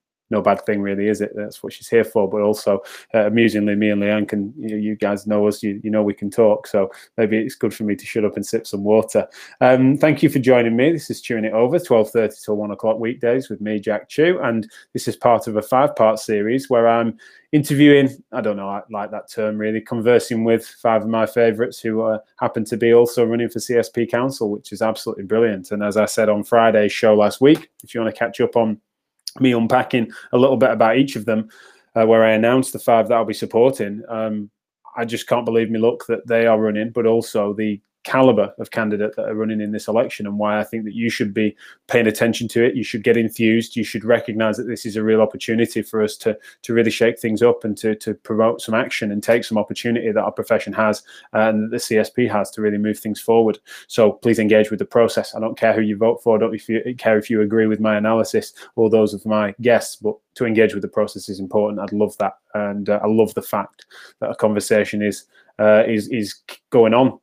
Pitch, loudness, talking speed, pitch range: 110 Hz, -19 LUFS, 240 wpm, 105-115 Hz